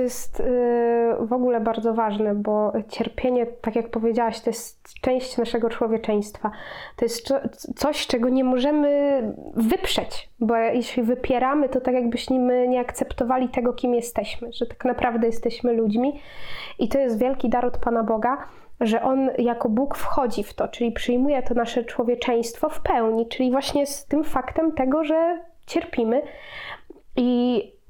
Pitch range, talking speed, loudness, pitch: 235-265 Hz, 150 wpm, -23 LUFS, 245 Hz